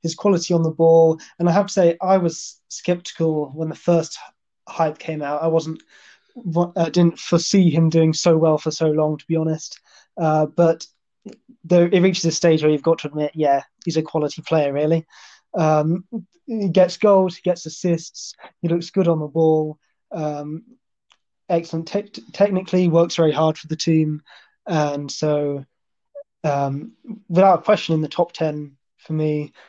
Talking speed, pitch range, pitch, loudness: 175 wpm, 155-180 Hz, 165 Hz, -19 LUFS